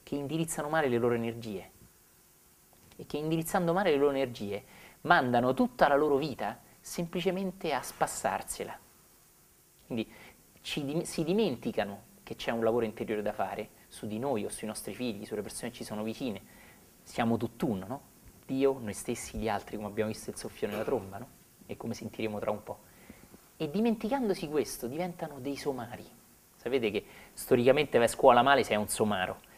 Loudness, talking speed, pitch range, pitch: -31 LUFS, 170 wpm, 110-155 Hz, 120 Hz